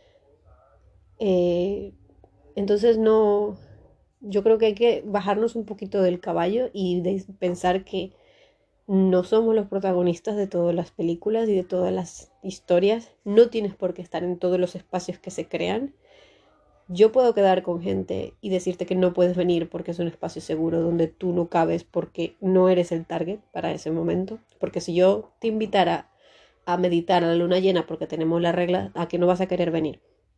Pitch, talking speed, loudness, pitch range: 185 Hz, 180 wpm, -23 LUFS, 175-205 Hz